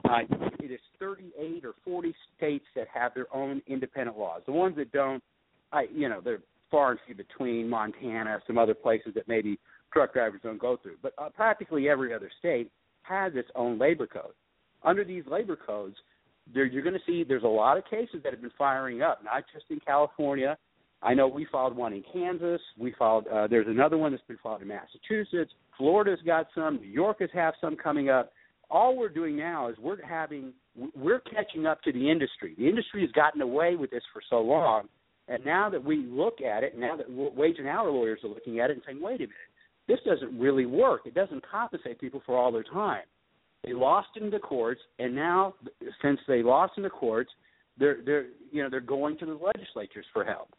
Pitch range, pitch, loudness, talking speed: 125-190 Hz, 145 Hz, -29 LUFS, 210 wpm